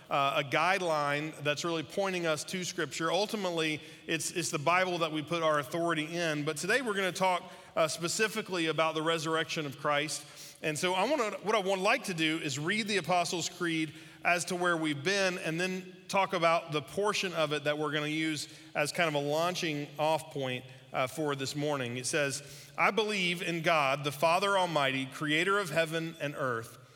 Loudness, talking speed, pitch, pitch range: -31 LUFS, 205 wpm, 160 Hz, 150-180 Hz